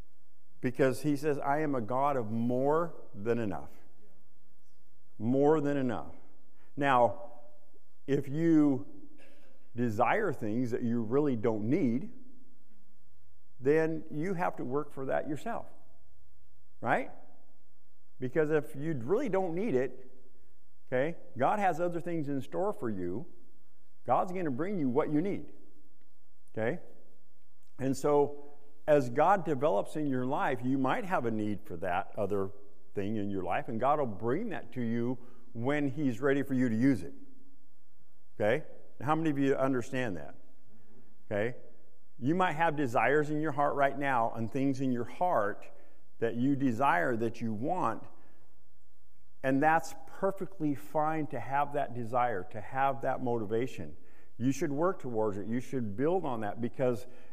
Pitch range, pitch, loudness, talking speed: 115-150 Hz, 130 Hz, -32 LUFS, 150 wpm